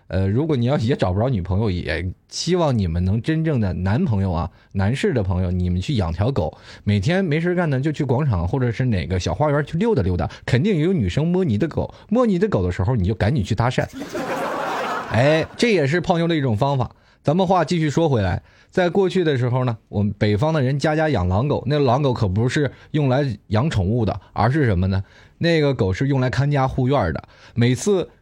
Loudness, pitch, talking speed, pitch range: -20 LUFS, 120 Hz, 320 characters per minute, 100-150 Hz